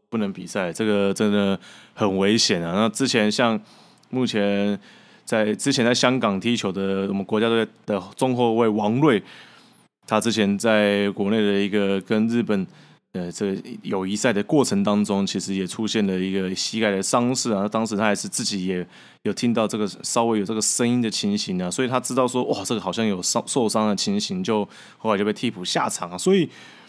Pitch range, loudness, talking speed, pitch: 100-120 Hz, -22 LUFS, 290 characters per minute, 105 Hz